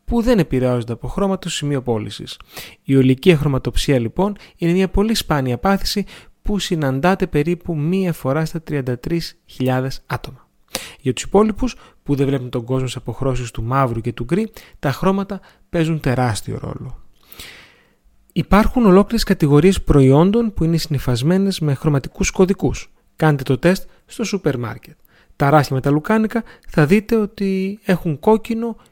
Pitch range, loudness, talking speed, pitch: 135-195 Hz, -18 LUFS, 145 wpm, 160 Hz